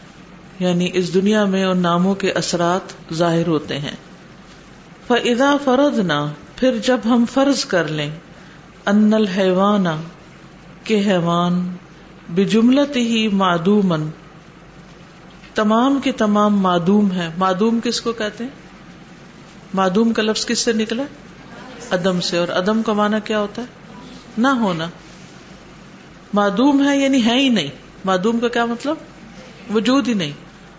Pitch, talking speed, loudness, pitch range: 195 Hz, 125 wpm, -18 LUFS, 175-230 Hz